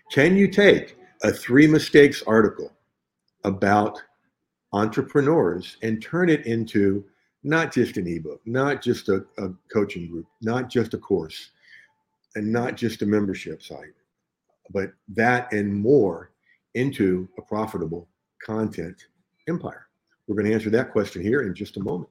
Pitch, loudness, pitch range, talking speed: 110 Hz, -22 LUFS, 100-135 Hz, 145 wpm